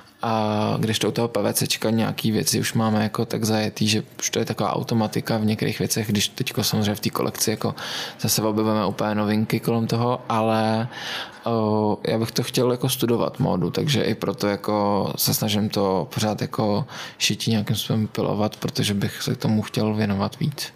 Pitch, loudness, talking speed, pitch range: 110 Hz, -23 LUFS, 180 wpm, 105-115 Hz